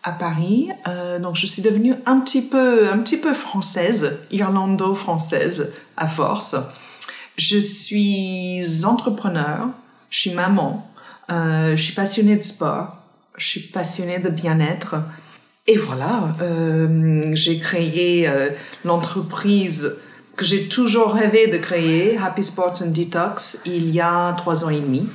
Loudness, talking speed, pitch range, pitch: -19 LUFS, 140 wpm, 170-210 Hz, 185 Hz